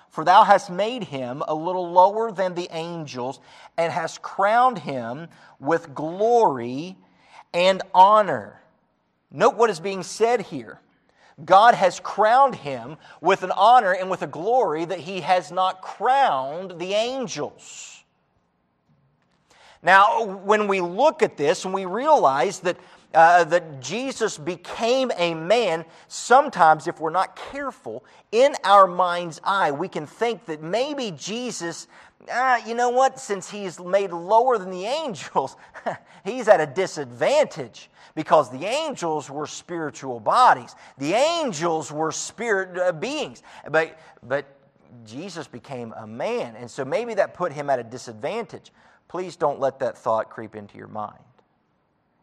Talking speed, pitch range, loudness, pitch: 145 wpm, 155-215 Hz, -21 LUFS, 180 Hz